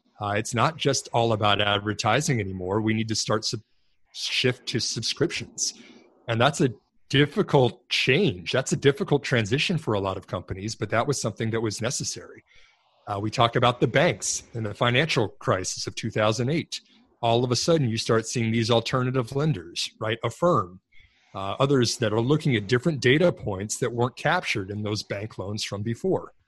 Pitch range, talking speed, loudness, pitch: 110-135 Hz, 185 wpm, -25 LUFS, 115 Hz